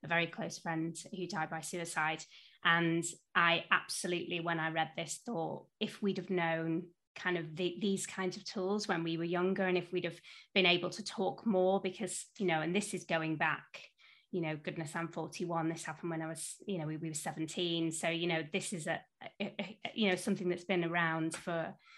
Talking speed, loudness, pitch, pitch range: 220 wpm, -36 LUFS, 175 Hz, 165-190 Hz